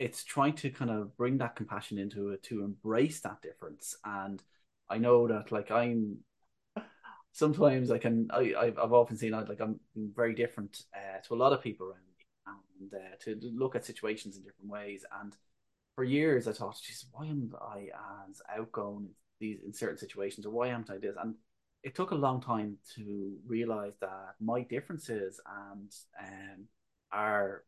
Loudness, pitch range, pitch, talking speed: -34 LUFS, 100-120 Hz, 110 Hz, 180 wpm